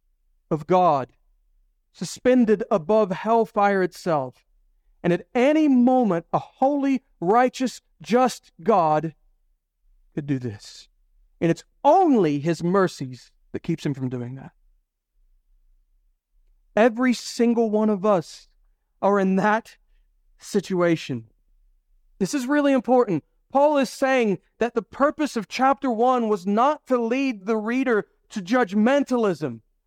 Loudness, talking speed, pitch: -22 LUFS, 120 wpm, 200 Hz